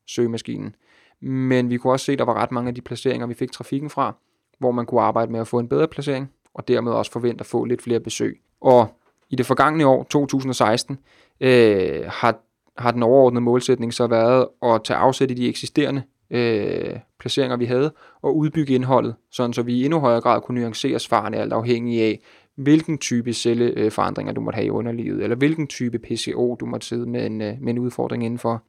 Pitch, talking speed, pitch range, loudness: 120 Hz, 205 wpm, 120-130 Hz, -21 LUFS